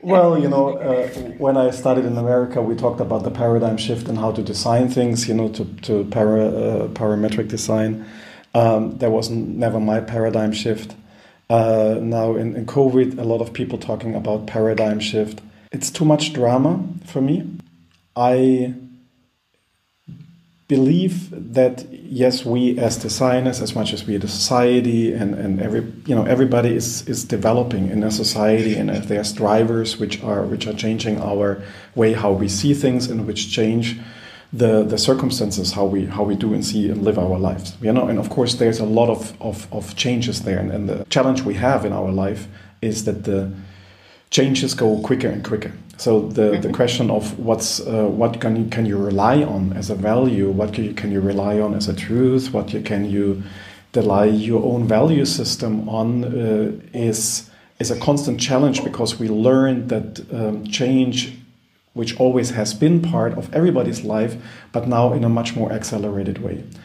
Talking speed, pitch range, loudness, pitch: 190 wpm, 105-125 Hz, -19 LUFS, 110 Hz